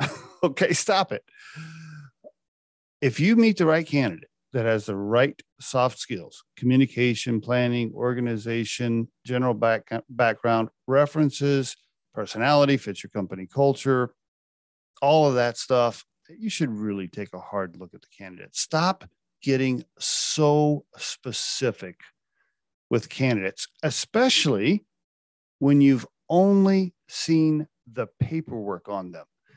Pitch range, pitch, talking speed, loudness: 110-150 Hz, 125 Hz, 115 wpm, -24 LUFS